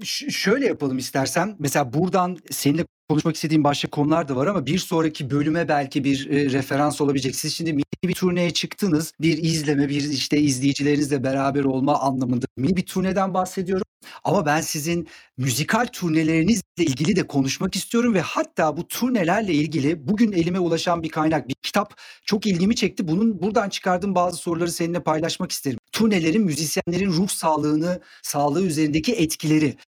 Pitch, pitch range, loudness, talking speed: 160 Hz, 145-185 Hz, -22 LUFS, 160 wpm